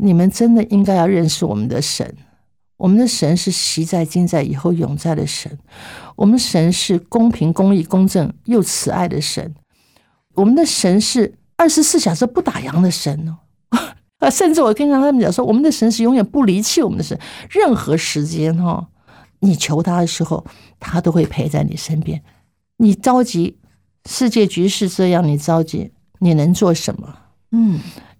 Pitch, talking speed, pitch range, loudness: 180 Hz, 255 characters per minute, 160-225 Hz, -16 LUFS